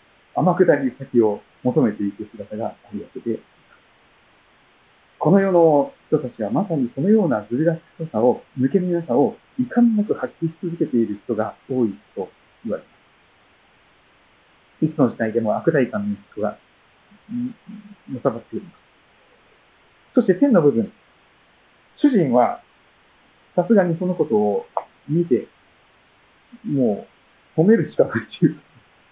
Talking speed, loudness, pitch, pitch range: 260 characters per minute, -21 LUFS, 170 Hz, 130-210 Hz